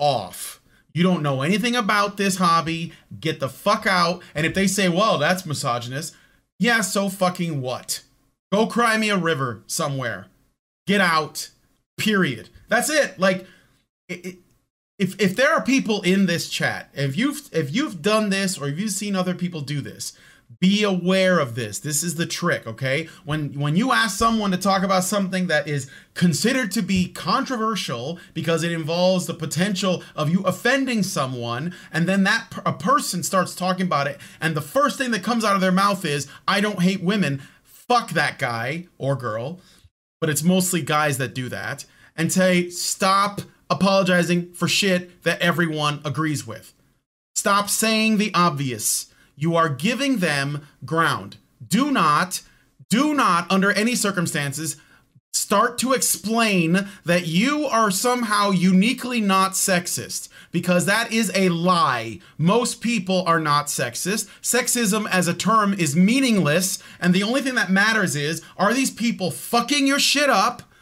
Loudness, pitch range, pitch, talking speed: -21 LUFS, 155-205 Hz, 180 Hz, 165 wpm